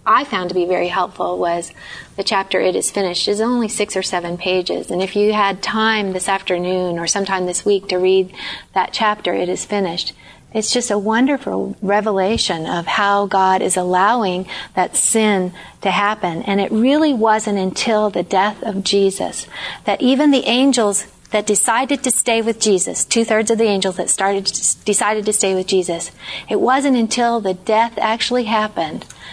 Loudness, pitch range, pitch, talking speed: -17 LUFS, 185-220 Hz, 205 Hz, 180 wpm